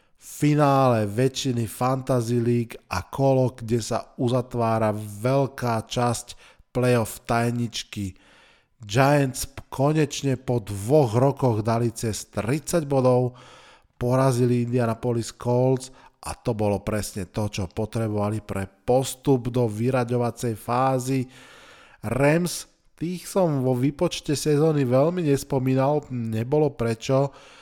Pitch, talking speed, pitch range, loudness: 125 Hz, 100 wpm, 115-135 Hz, -24 LUFS